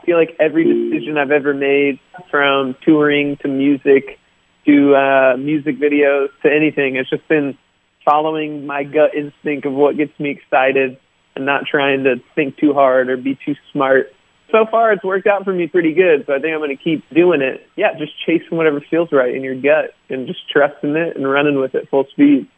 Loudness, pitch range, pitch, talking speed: -16 LUFS, 140-160 Hz, 145 Hz, 205 wpm